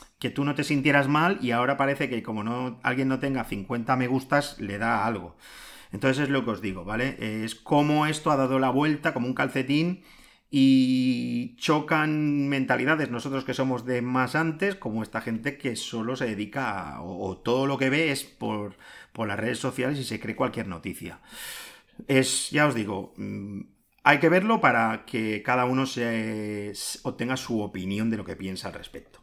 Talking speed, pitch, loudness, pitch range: 195 wpm, 130 Hz, -26 LUFS, 110-145 Hz